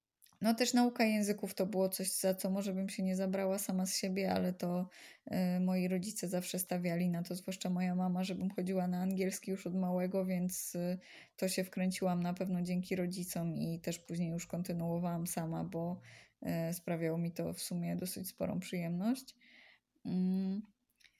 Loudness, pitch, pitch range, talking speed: -37 LUFS, 185 Hz, 180-190 Hz, 175 wpm